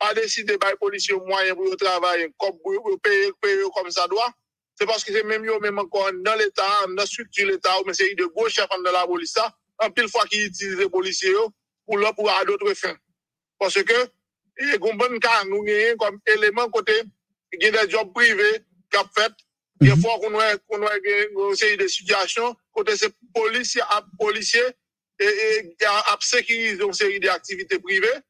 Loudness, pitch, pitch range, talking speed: -21 LUFS, 215 Hz, 195-245 Hz, 210 wpm